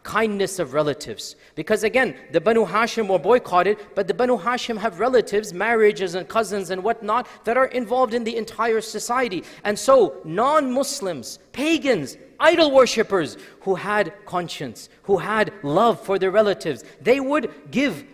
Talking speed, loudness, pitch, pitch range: 155 wpm, -21 LUFS, 215 Hz, 190-245 Hz